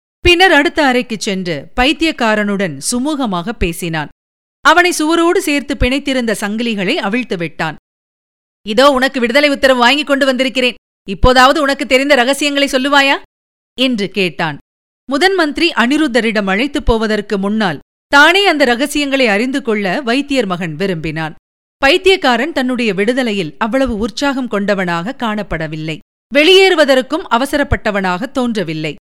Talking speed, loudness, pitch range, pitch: 105 wpm, -13 LUFS, 200-285 Hz, 250 Hz